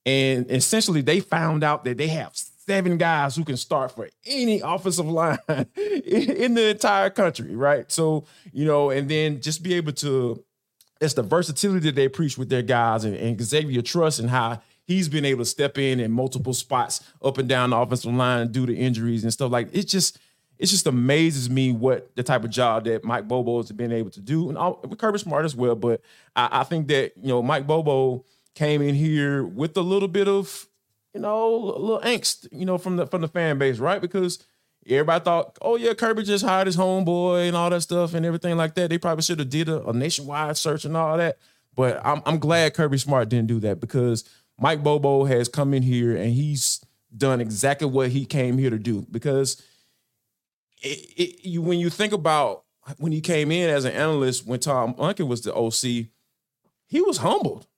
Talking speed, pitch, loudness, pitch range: 210 wpm, 145 Hz, -23 LUFS, 125-170 Hz